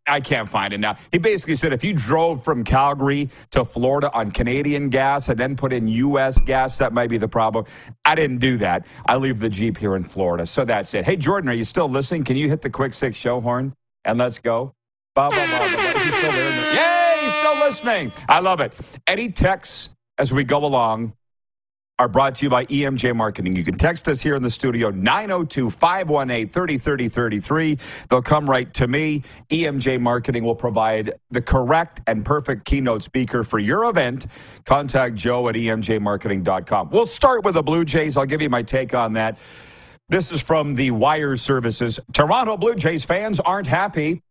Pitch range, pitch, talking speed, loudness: 115-150 Hz, 135 Hz, 185 wpm, -20 LUFS